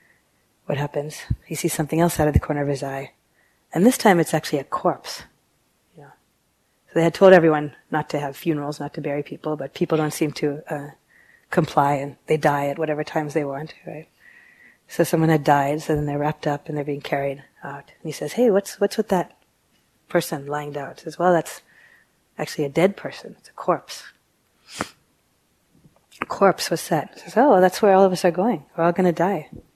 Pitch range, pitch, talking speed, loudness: 145-175 Hz, 155 Hz, 210 wpm, -22 LUFS